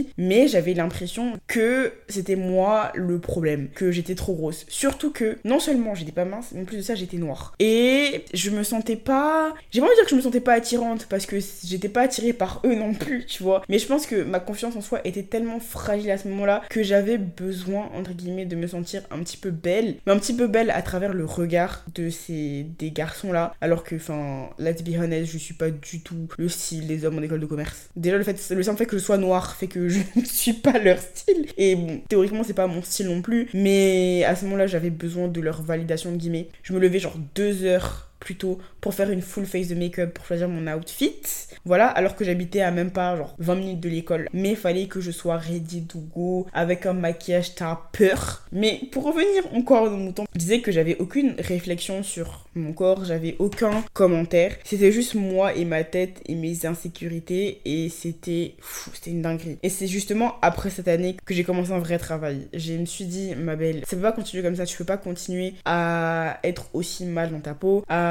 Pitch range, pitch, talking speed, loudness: 170-205 Hz, 185 Hz, 235 wpm, -24 LUFS